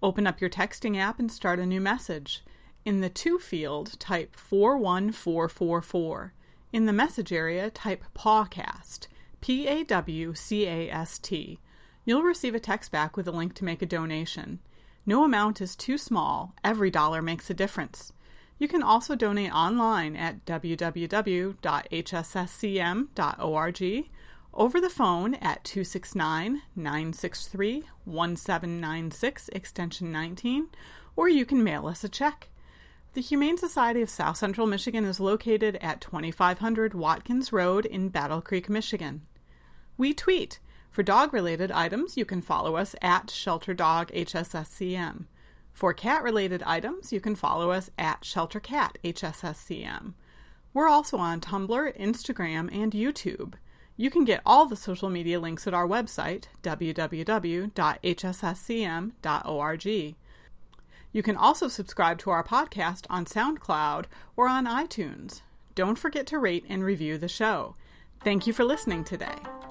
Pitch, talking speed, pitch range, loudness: 190 Hz, 135 wpm, 170-225 Hz, -28 LUFS